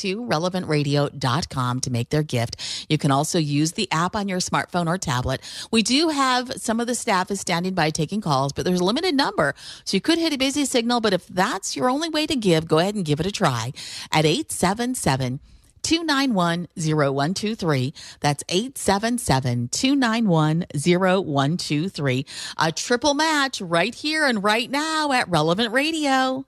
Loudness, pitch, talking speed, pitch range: -22 LUFS, 180 Hz, 165 wpm, 150-245 Hz